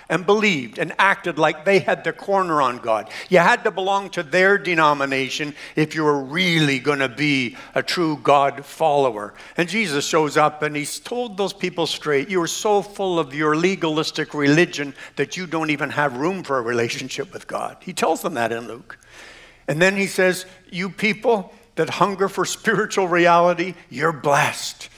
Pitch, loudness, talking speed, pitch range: 165 Hz, -20 LUFS, 180 wpm, 145-190 Hz